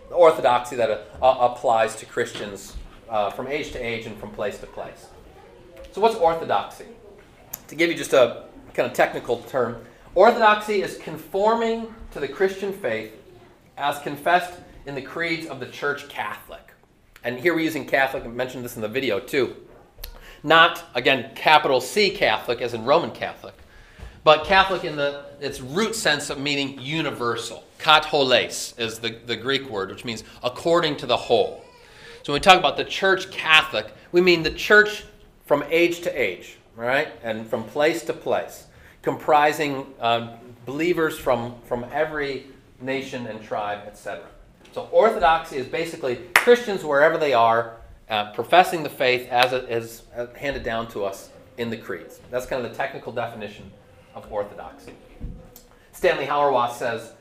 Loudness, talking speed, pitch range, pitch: -22 LUFS, 155 wpm, 115-165 Hz, 135 Hz